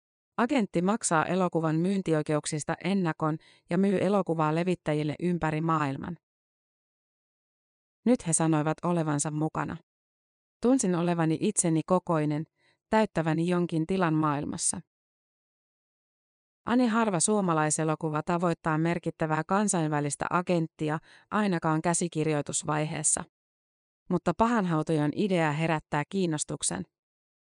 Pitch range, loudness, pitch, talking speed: 155-180 Hz, -28 LUFS, 165 Hz, 85 wpm